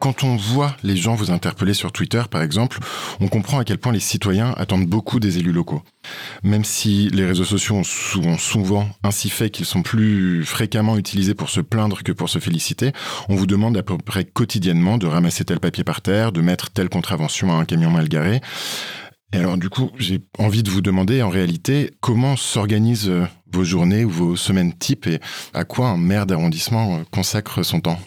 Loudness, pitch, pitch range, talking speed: -19 LUFS, 100 Hz, 90-115 Hz, 205 wpm